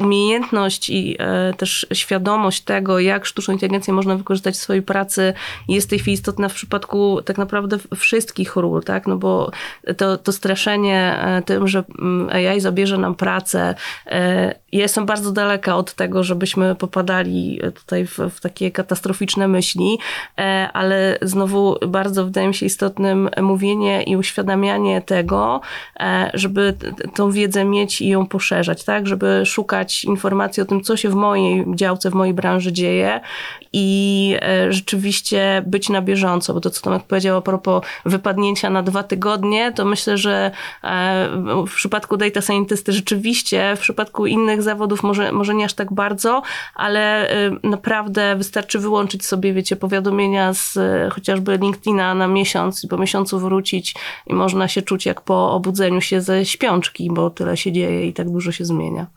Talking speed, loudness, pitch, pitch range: 155 wpm, -18 LUFS, 195 Hz, 185-205 Hz